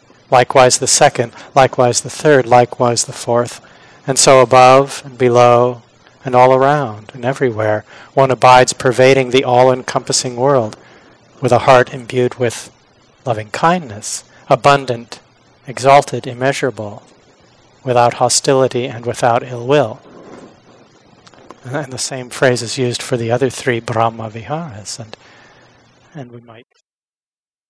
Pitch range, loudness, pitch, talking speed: 120-135 Hz, -13 LUFS, 125 Hz, 125 wpm